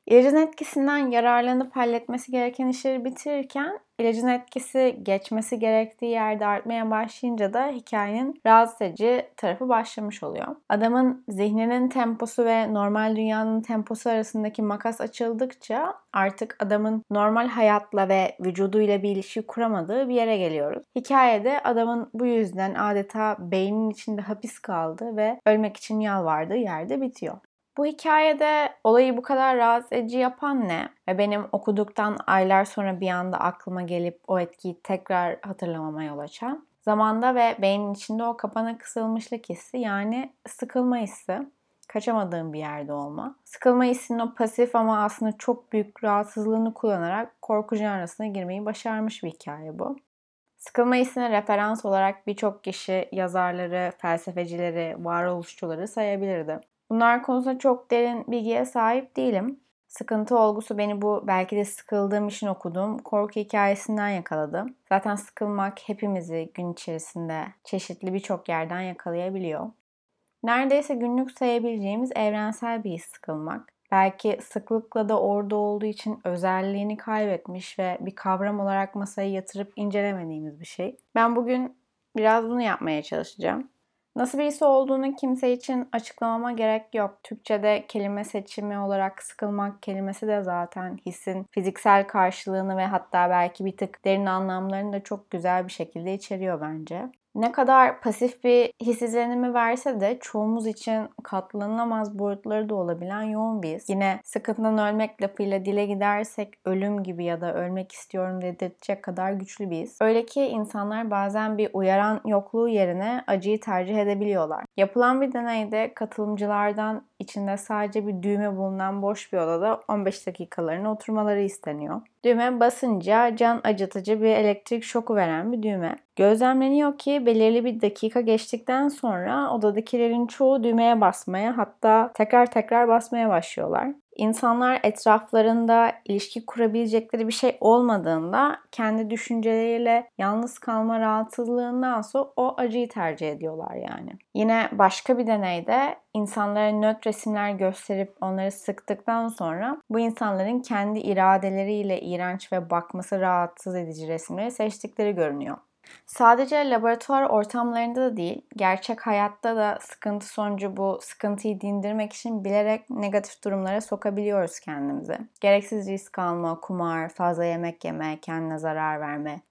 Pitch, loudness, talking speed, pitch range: 215 Hz, -25 LUFS, 130 wpm, 195-235 Hz